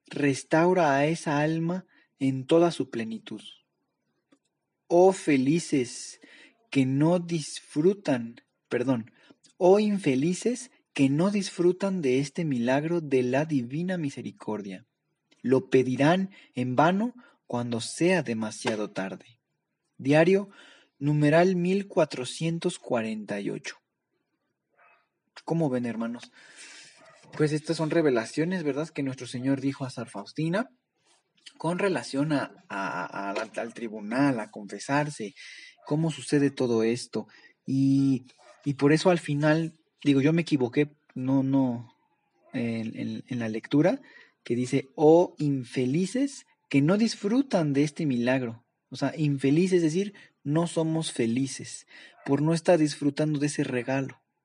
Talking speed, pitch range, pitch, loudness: 120 wpm, 130-170 Hz, 145 Hz, -27 LUFS